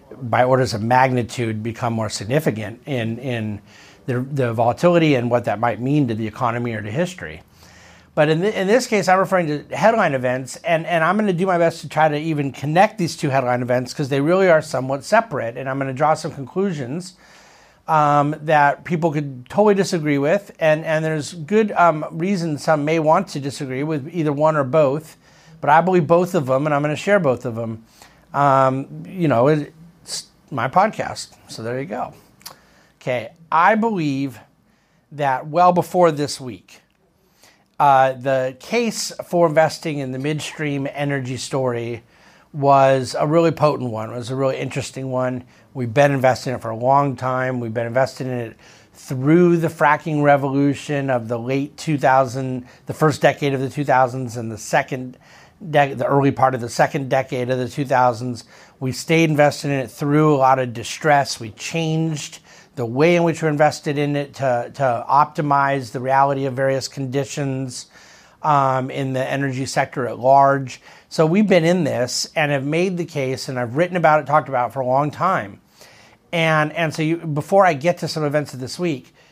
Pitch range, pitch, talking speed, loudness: 130-160 Hz, 140 Hz, 190 wpm, -19 LUFS